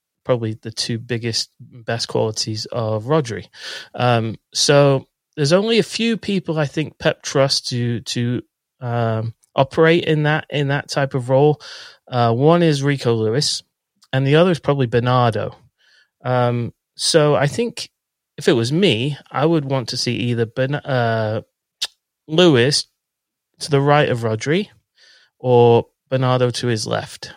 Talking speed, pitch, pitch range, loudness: 150 wpm, 130 Hz, 120-150 Hz, -18 LUFS